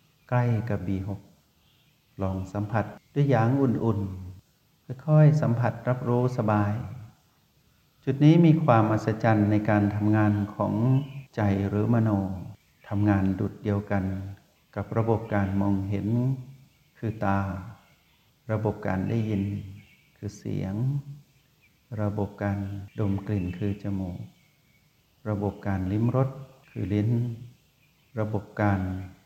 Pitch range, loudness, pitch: 100-120 Hz, -26 LUFS, 105 Hz